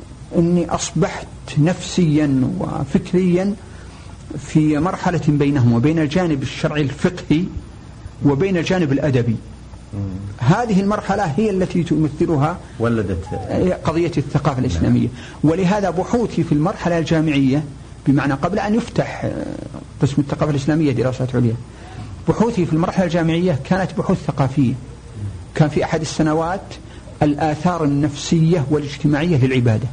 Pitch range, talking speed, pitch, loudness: 130-175 Hz, 105 wpm, 150 Hz, -18 LUFS